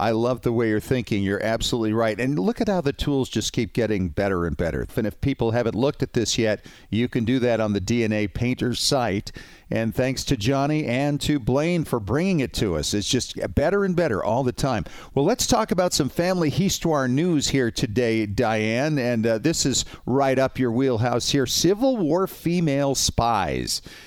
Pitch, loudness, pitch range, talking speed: 125 Hz, -23 LUFS, 110-145 Hz, 205 wpm